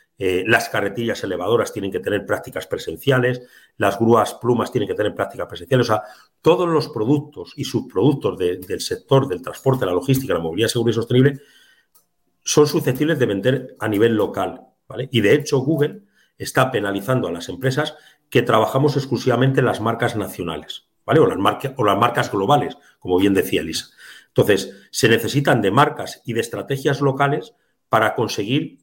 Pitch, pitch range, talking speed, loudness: 130 Hz, 115-145 Hz, 175 wpm, -20 LUFS